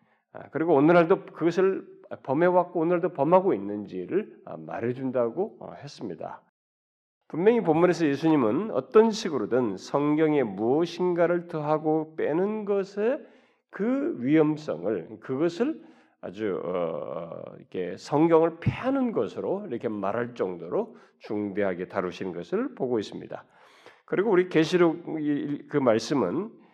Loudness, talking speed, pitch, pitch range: -26 LUFS, 275 characters per minute, 170 Hz, 140-215 Hz